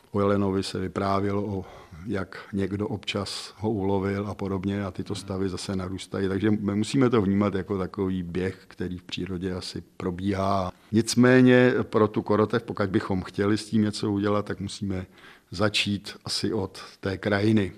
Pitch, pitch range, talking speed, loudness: 100 Hz, 95-105 Hz, 160 wpm, -26 LUFS